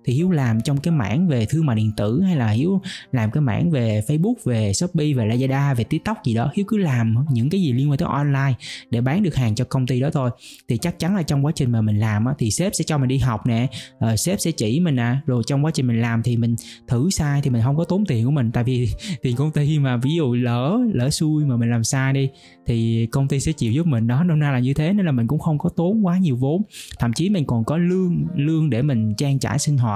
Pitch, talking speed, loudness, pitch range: 135 Hz, 275 wpm, -20 LUFS, 120-160 Hz